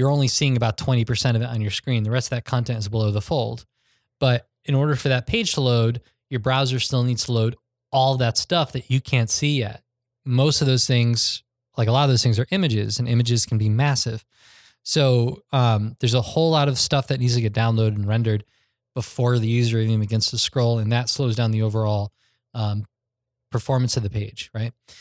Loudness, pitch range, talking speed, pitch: -21 LUFS, 115-130 Hz, 220 wpm, 120 Hz